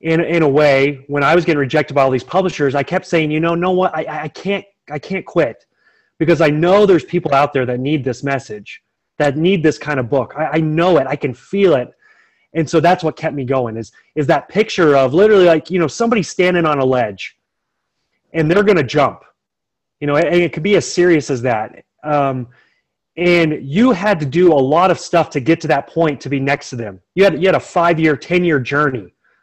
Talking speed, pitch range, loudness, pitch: 235 wpm, 140-175 Hz, -15 LUFS, 155 Hz